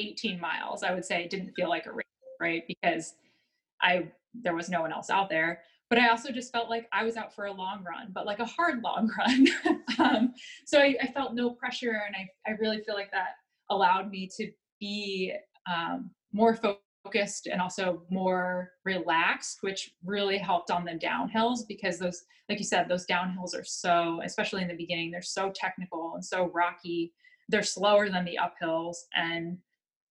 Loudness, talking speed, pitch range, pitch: -30 LUFS, 190 wpm, 180-225 Hz, 195 Hz